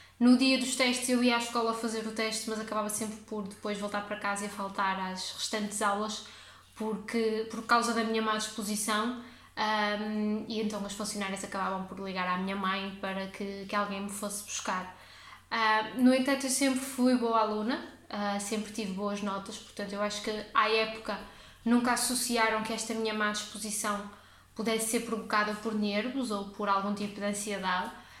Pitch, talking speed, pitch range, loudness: 215 Hz, 185 wpm, 205-225 Hz, -31 LUFS